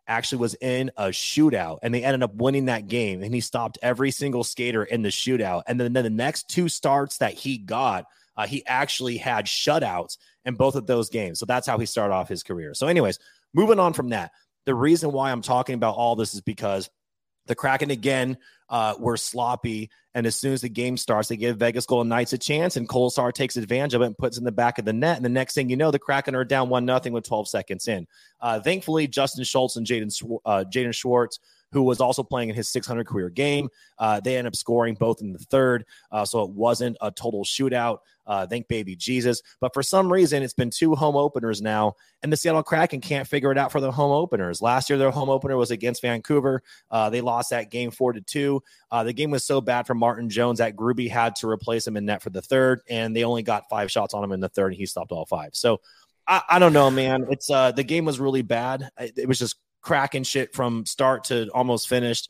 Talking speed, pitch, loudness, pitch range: 240 wpm, 125 Hz, -24 LUFS, 115-135 Hz